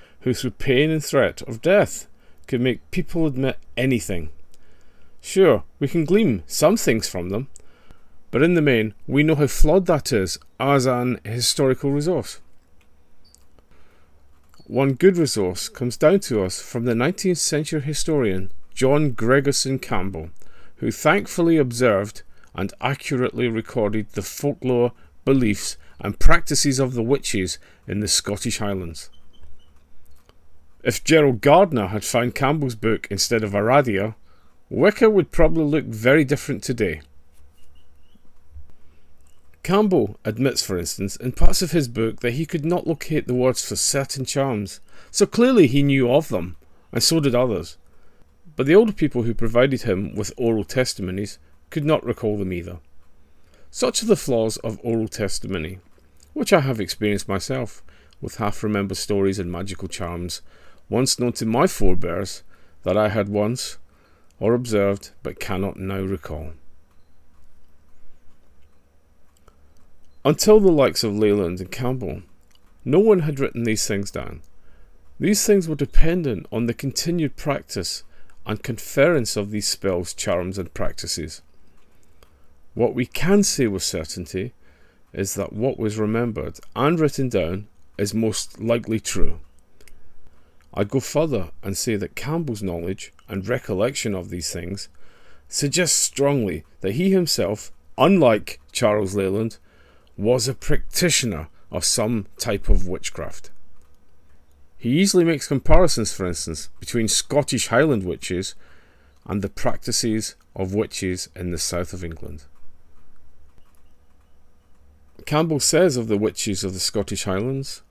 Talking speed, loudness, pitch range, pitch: 135 wpm, -21 LUFS, 80-130 Hz, 105 Hz